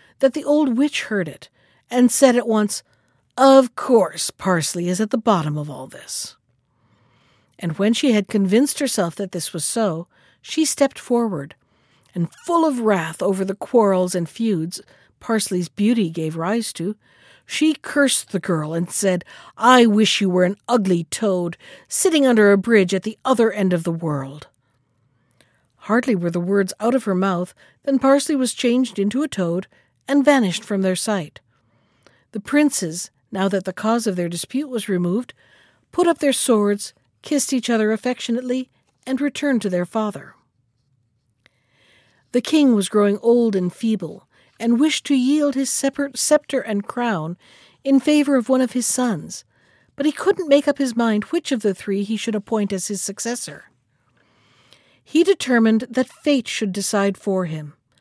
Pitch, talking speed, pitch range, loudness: 210 Hz, 170 wpm, 175-255 Hz, -19 LUFS